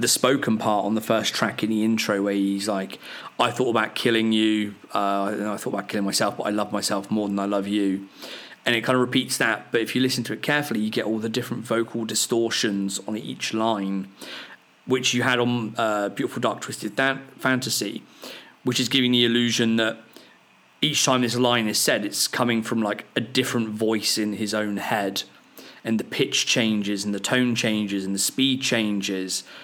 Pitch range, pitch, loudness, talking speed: 105-120 Hz, 110 Hz, -23 LUFS, 205 wpm